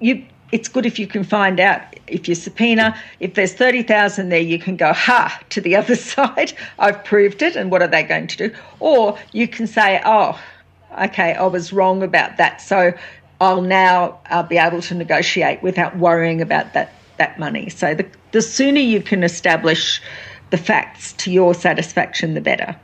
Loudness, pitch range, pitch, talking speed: -16 LUFS, 175-215 Hz, 190 Hz, 190 wpm